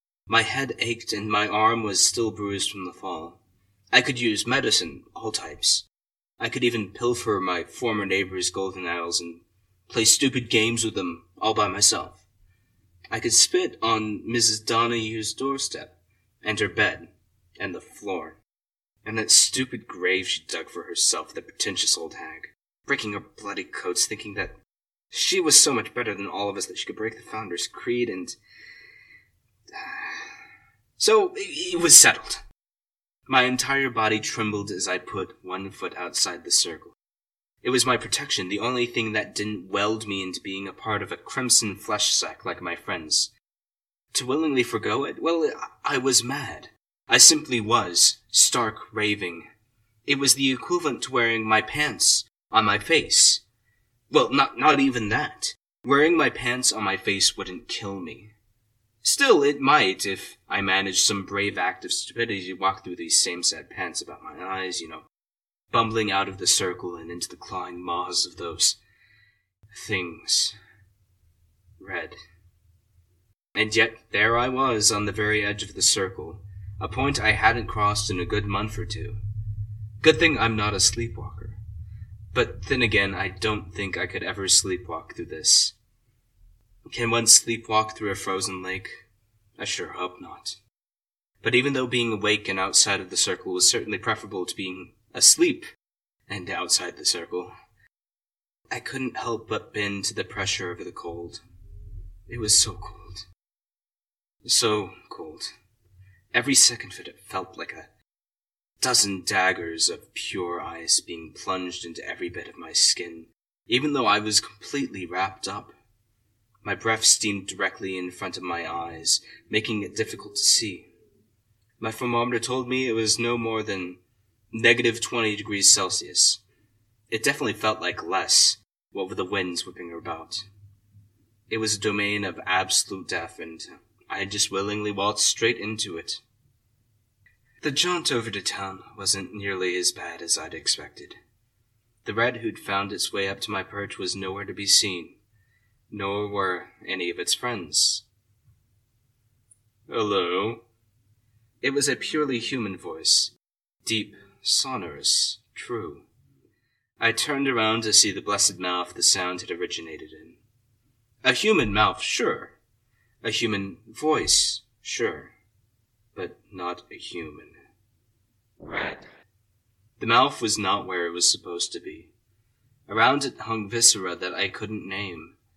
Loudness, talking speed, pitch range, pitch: -23 LUFS, 155 wpm, 95-115 Hz, 105 Hz